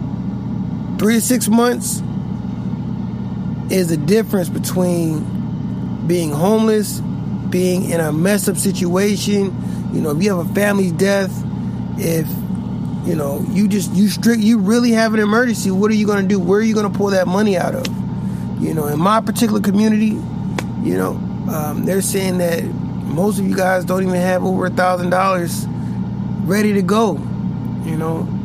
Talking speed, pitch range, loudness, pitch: 165 wpm, 180-210 Hz, -17 LUFS, 195 Hz